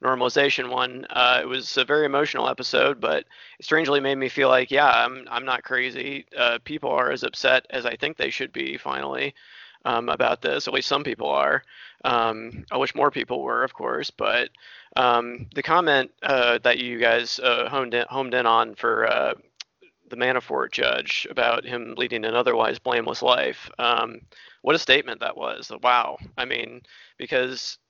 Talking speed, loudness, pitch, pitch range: 185 wpm, -23 LUFS, 125 Hz, 120-135 Hz